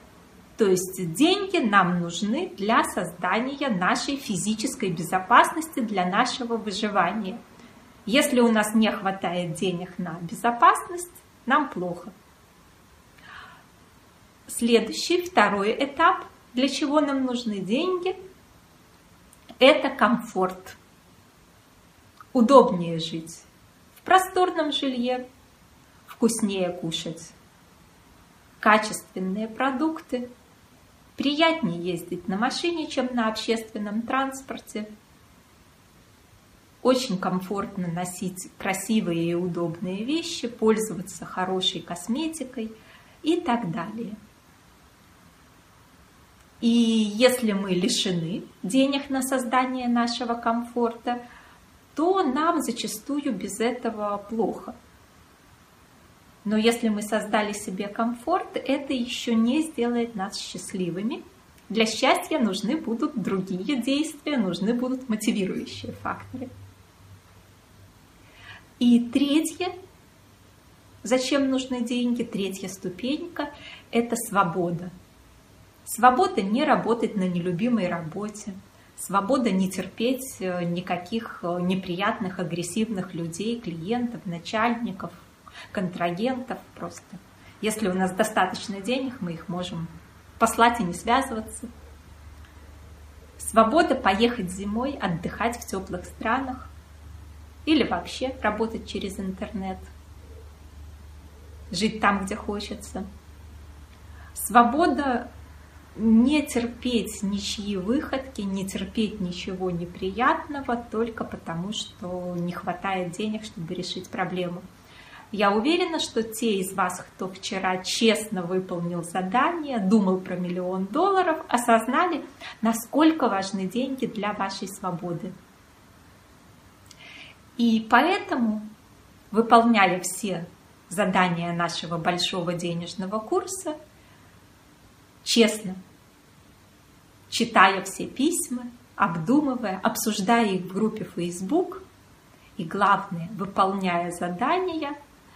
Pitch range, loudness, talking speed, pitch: 185-245 Hz, -25 LUFS, 90 wpm, 215 Hz